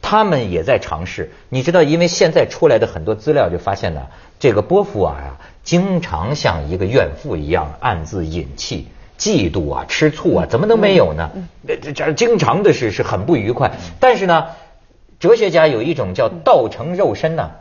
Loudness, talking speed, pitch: -16 LUFS, 280 characters per minute, 165 Hz